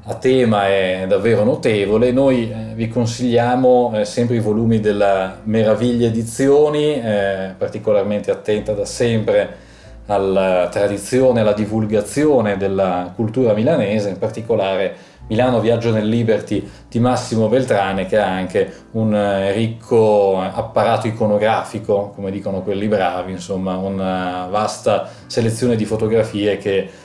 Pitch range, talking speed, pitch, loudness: 100-115 Hz, 115 wpm, 110 Hz, -17 LUFS